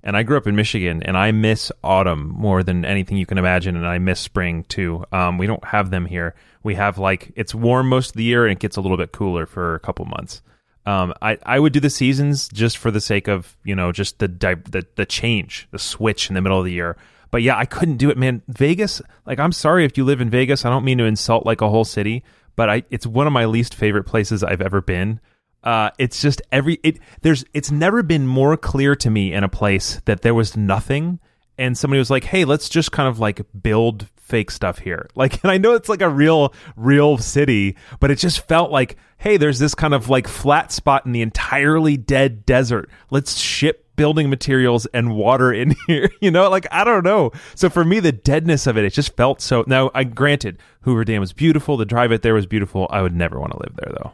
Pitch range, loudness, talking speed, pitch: 100-140 Hz, -18 LUFS, 245 wpm, 115 Hz